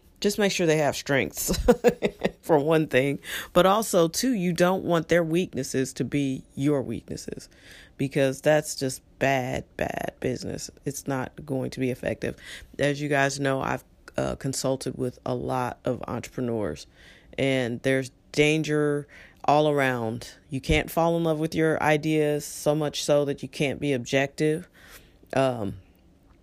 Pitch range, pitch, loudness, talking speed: 130-155 Hz, 140 Hz, -26 LUFS, 150 wpm